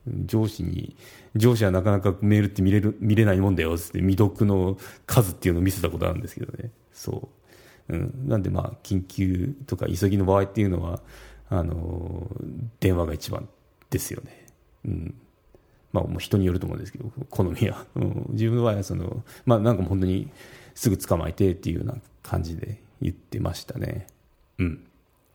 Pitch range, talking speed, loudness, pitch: 90-120 Hz, 355 characters per minute, -25 LUFS, 100 Hz